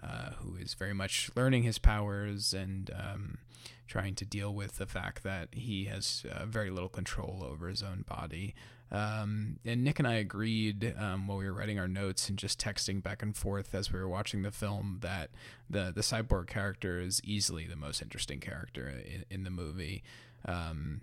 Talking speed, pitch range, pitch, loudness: 195 wpm, 95-110 Hz, 100 Hz, -36 LUFS